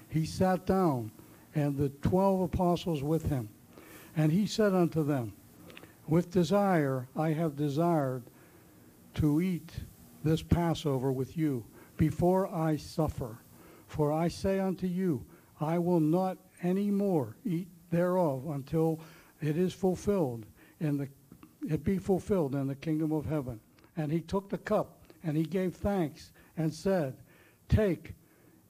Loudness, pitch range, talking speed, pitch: -31 LUFS, 145-180 Hz, 140 wpm, 160 Hz